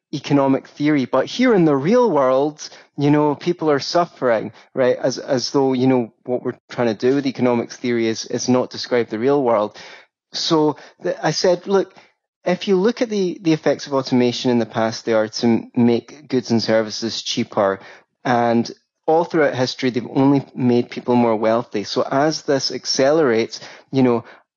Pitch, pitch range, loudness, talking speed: 130 Hz, 120-150 Hz, -19 LUFS, 185 wpm